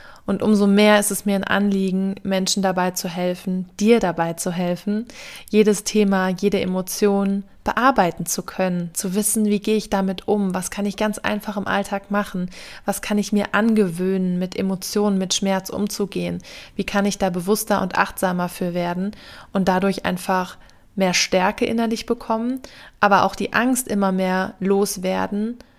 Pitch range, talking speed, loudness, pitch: 185-210 Hz, 165 wpm, -21 LUFS, 200 Hz